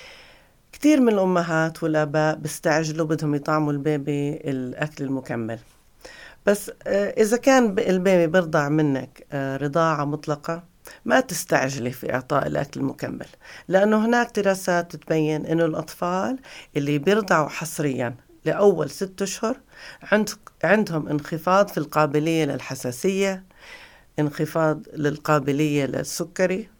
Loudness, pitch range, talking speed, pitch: -23 LUFS, 150-195 Hz, 100 wpm, 160 Hz